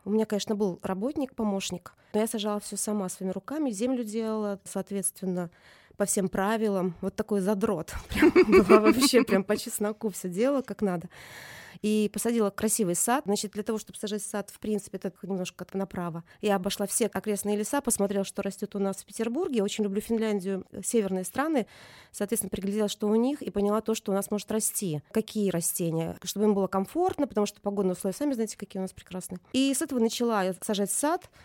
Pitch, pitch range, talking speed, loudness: 205 Hz, 195-220 Hz, 190 wpm, -28 LUFS